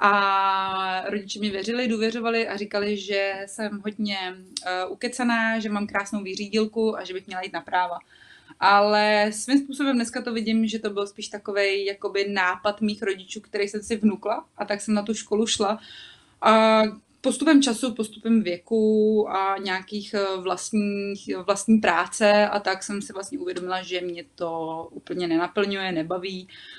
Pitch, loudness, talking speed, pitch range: 205 Hz, -24 LUFS, 155 wpm, 195-220 Hz